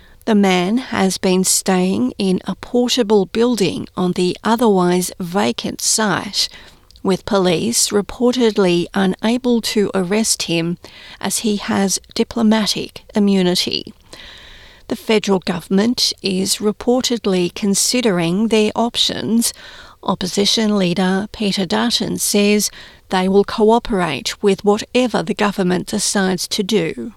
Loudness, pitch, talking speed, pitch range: -17 LUFS, 205 Hz, 110 wpm, 190-220 Hz